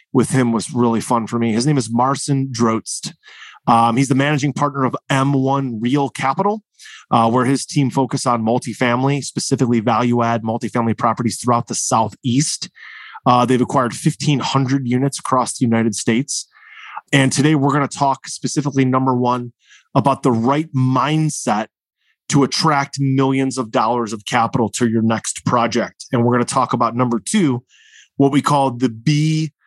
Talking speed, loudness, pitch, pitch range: 165 wpm, -17 LUFS, 130 Hz, 120-140 Hz